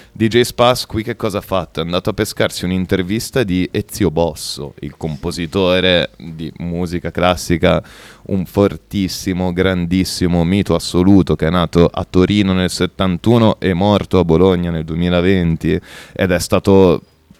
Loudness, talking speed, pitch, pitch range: -16 LUFS, 140 wpm, 90 Hz, 85-100 Hz